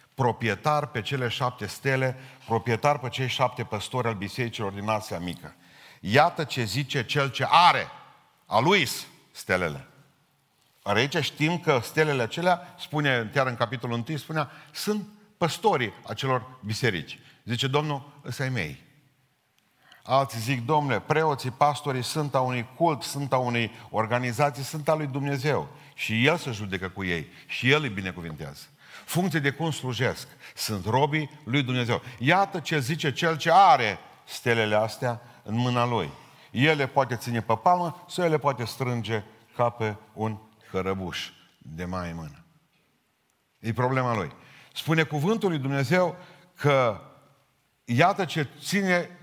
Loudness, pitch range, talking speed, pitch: -26 LUFS, 115-150 Hz, 145 wpm, 130 Hz